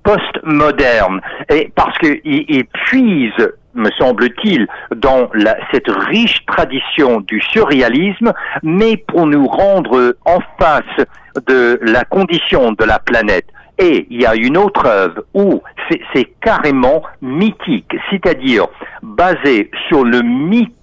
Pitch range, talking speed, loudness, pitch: 140-225 Hz, 125 wpm, -12 LUFS, 190 Hz